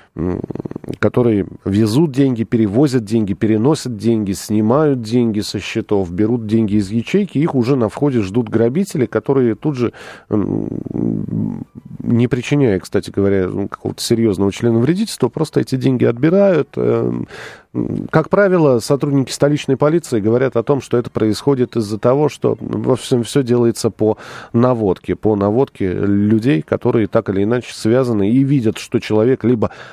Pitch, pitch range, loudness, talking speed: 120 Hz, 110-135 Hz, -16 LUFS, 135 wpm